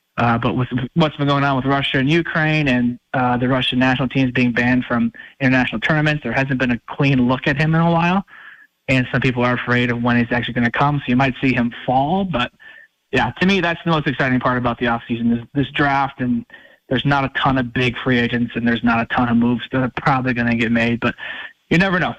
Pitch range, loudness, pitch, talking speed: 120-140 Hz, -18 LUFS, 130 Hz, 250 wpm